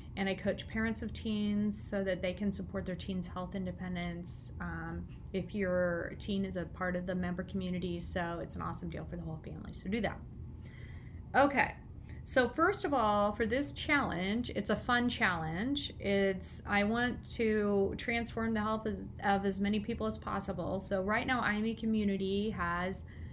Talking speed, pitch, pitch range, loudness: 180 wpm, 200 Hz, 180-220 Hz, -34 LUFS